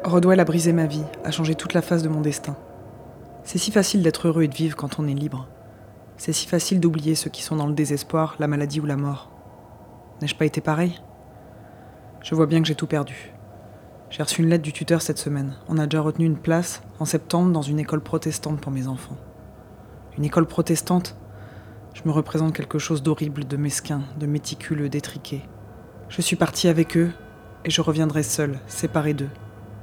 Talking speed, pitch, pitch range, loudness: 200 wpm, 150 Hz, 130-160 Hz, -23 LUFS